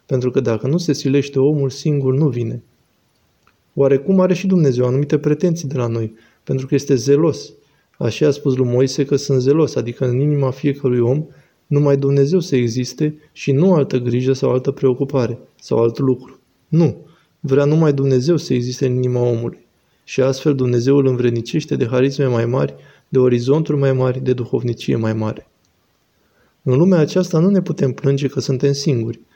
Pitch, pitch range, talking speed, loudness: 135 Hz, 125-145 Hz, 175 wpm, -17 LUFS